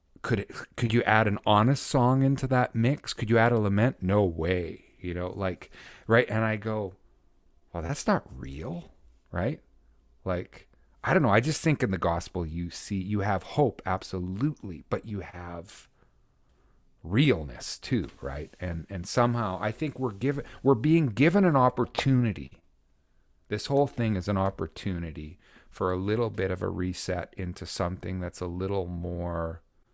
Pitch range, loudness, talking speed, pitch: 85-115 Hz, -28 LUFS, 165 wpm, 95 Hz